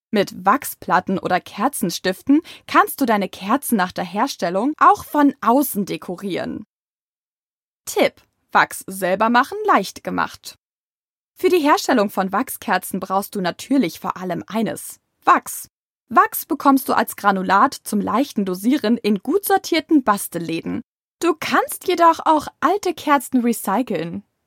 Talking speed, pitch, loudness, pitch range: 130 wpm, 240 Hz, -19 LUFS, 195-295 Hz